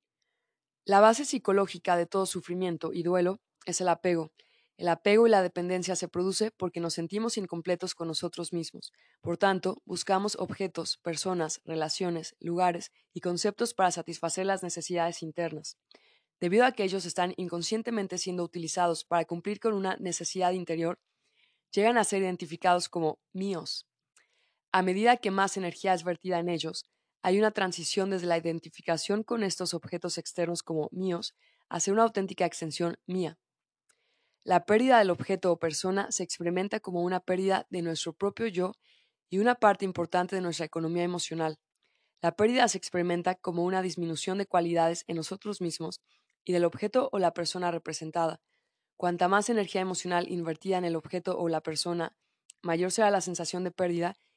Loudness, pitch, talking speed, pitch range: -29 LUFS, 180 Hz, 160 wpm, 170-195 Hz